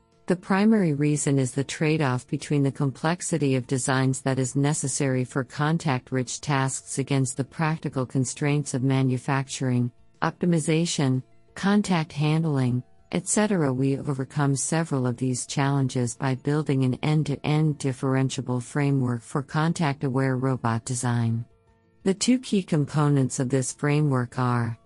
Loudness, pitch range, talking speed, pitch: -25 LUFS, 130-155 Hz, 125 wpm, 135 Hz